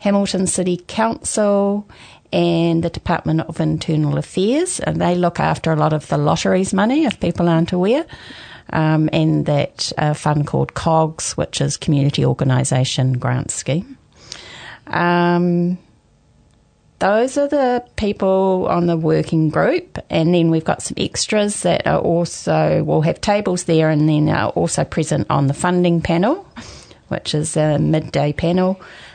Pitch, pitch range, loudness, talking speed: 170 Hz, 155-185 Hz, -18 LUFS, 150 wpm